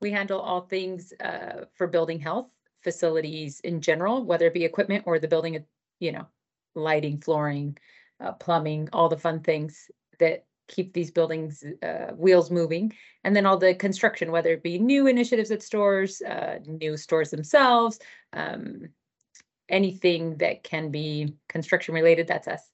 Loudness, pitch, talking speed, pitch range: -25 LUFS, 170 Hz, 160 wpm, 160-200 Hz